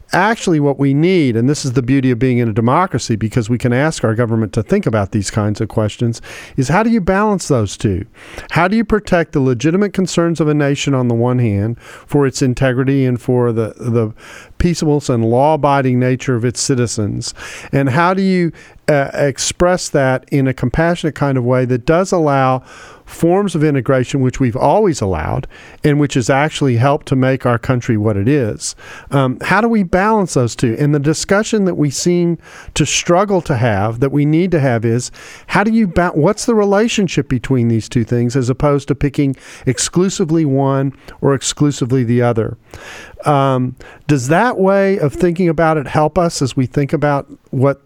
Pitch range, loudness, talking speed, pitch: 125-165 Hz, -15 LUFS, 195 wpm, 140 Hz